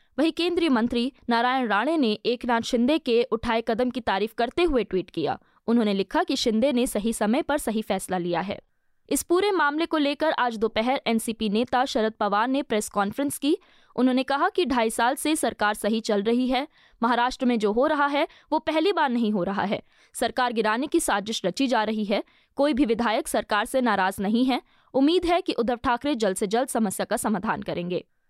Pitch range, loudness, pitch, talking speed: 220-285 Hz, -24 LUFS, 240 Hz, 205 wpm